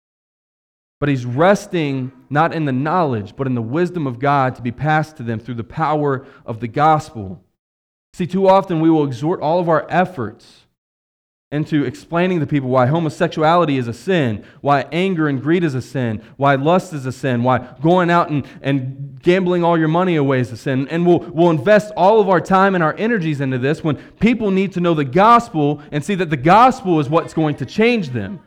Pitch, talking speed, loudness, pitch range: 155 Hz, 210 wpm, -17 LUFS, 130-175 Hz